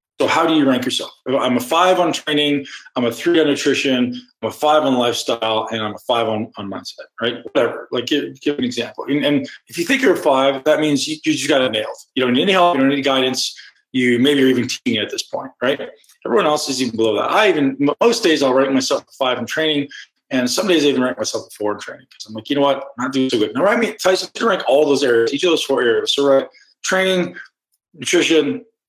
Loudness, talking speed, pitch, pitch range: -17 LUFS, 265 wpm, 145 Hz, 130-180 Hz